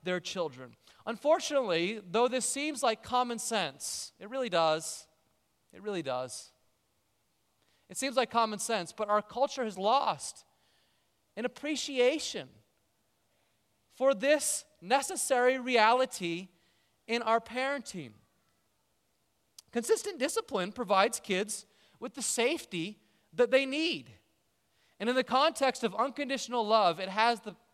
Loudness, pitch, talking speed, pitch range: -31 LUFS, 225 Hz, 115 wpm, 175-260 Hz